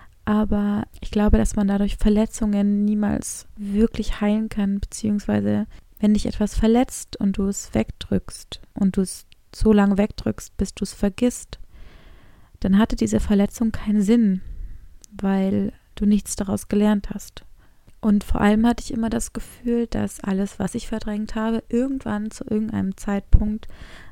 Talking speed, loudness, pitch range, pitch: 150 wpm, -22 LUFS, 195-220 Hz, 210 Hz